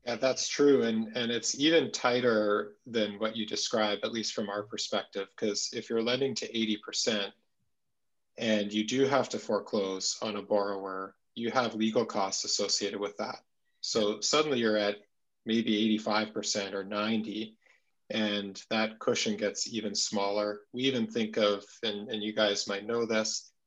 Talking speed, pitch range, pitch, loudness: 160 wpm, 105-115 Hz, 110 Hz, -30 LUFS